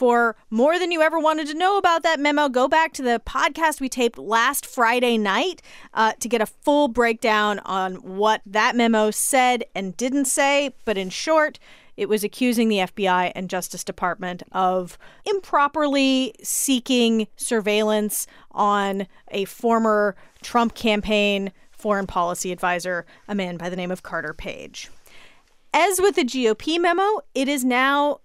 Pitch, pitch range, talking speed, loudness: 230 Hz, 200-280 Hz, 155 wpm, -21 LUFS